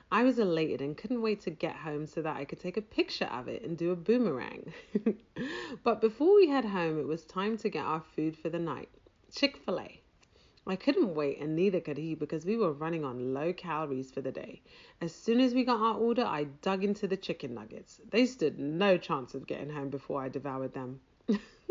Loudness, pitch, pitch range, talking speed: -32 LUFS, 175 Hz, 155-225 Hz, 220 wpm